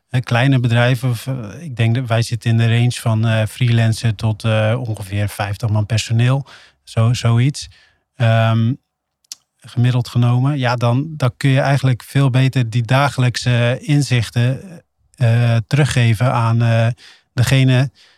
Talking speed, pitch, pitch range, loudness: 125 wpm, 120 Hz, 115-130 Hz, -16 LUFS